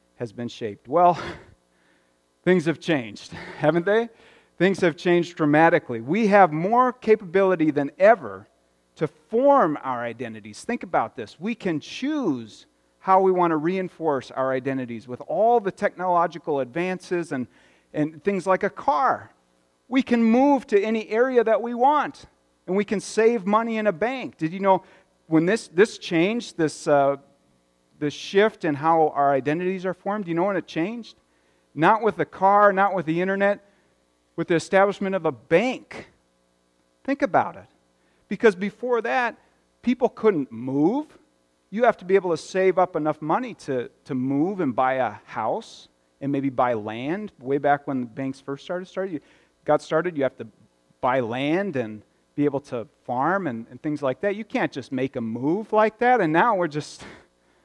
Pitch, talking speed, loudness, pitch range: 165 Hz, 175 wpm, -23 LUFS, 130-205 Hz